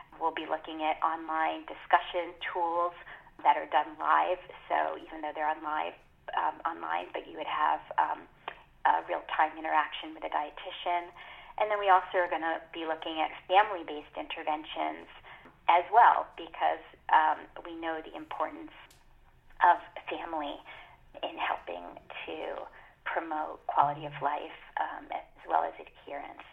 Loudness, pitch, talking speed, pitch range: -31 LUFS, 165 Hz, 145 wpm, 155-175 Hz